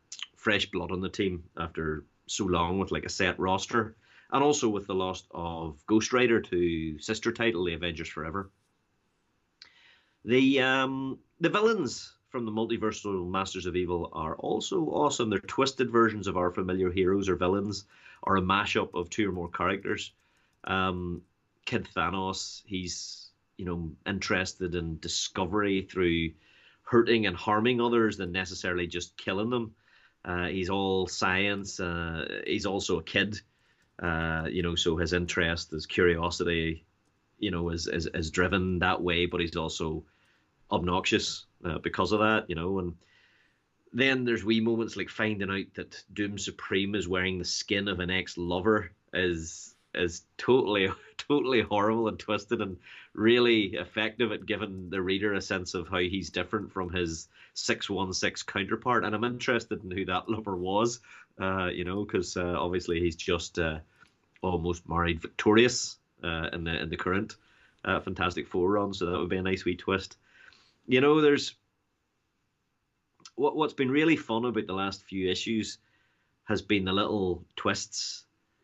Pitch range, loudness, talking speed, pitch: 90-105 Hz, -29 LUFS, 160 wpm, 95 Hz